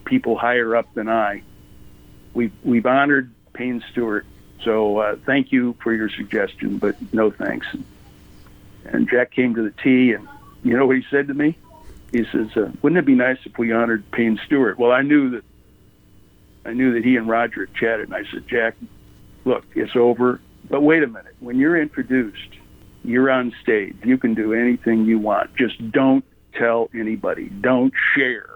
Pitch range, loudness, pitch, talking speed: 115-135 Hz, -19 LUFS, 120 Hz, 185 wpm